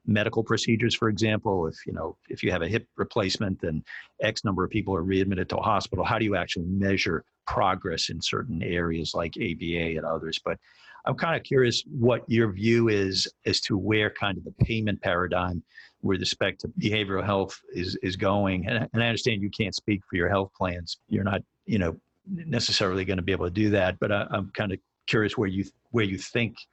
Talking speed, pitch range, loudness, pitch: 215 wpm, 95-115 Hz, -27 LUFS, 100 Hz